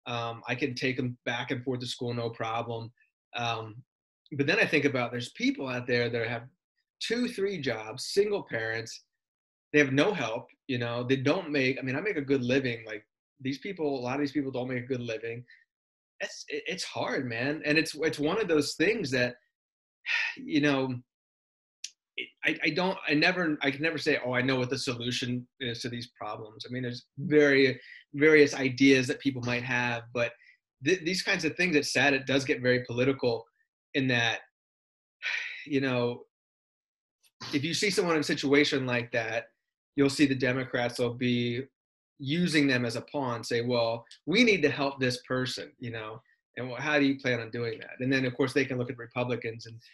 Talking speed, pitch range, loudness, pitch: 200 wpm, 120-145 Hz, -29 LUFS, 130 Hz